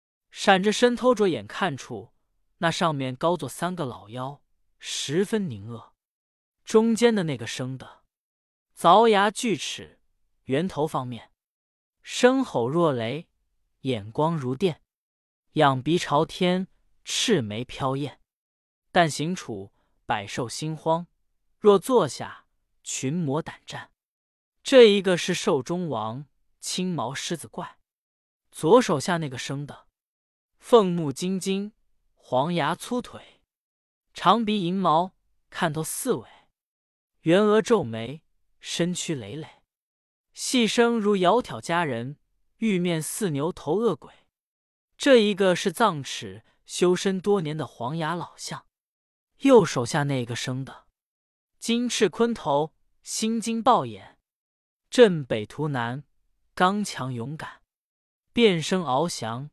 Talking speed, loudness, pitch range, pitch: 165 characters per minute, -24 LUFS, 135-200 Hz, 165 Hz